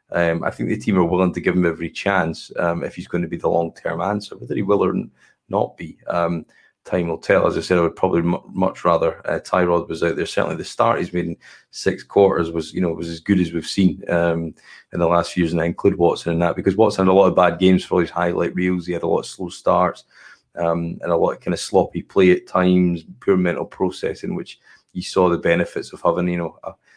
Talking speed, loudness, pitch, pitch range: 260 wpm, -20 LUFS, 85 Hz, 85-90 Hz